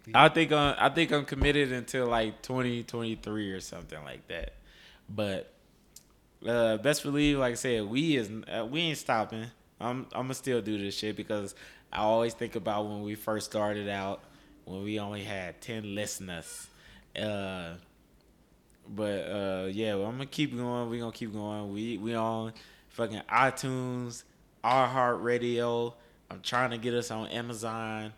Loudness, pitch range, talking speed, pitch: -31 LUFS, 105-125 Hz, 170 wpm, 115 Hz